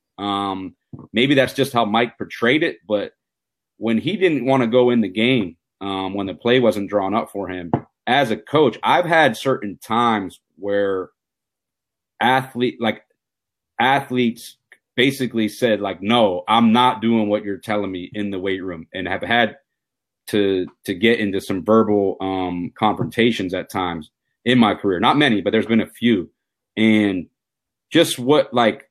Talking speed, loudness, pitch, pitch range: 165 wpm, -19 LUFS, 110 Hz, 95-120 Hz